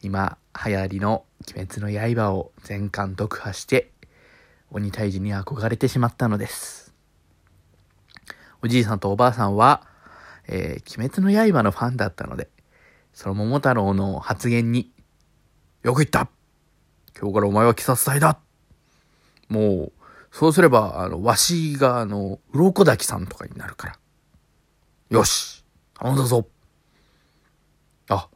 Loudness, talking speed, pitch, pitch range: -21 LUFS, 245 characters per minute, 105 Hz, 100-125 Hz